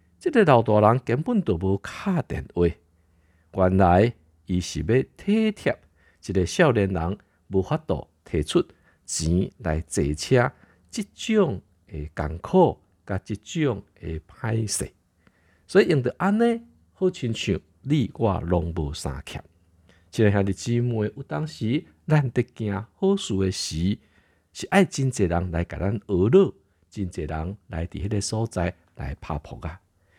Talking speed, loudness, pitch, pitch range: 195 characters per minute, -24 LUFS, 95 Hz, 85-120 Hz